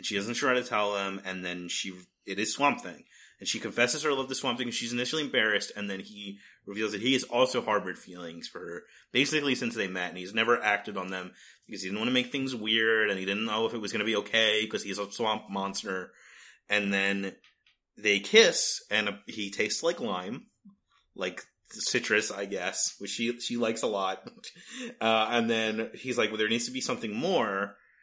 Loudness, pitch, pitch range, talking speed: -29 LUFS, 110 Hz, 100-125 Hz, 220 wpm